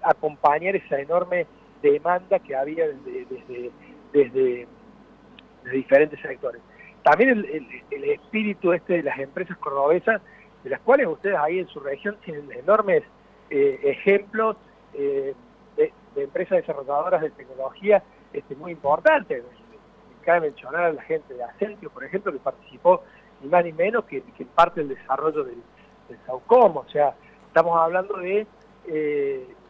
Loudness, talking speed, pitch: -23 LUFS, 150 wpm, 195 Hz